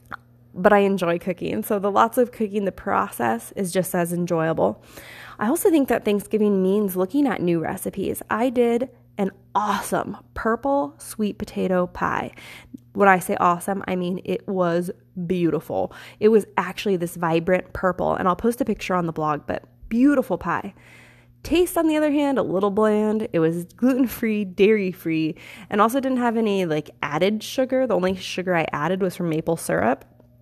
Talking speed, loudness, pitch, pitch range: 175 wpm, -22 LUFS, 195 Hz, 175-220 Hz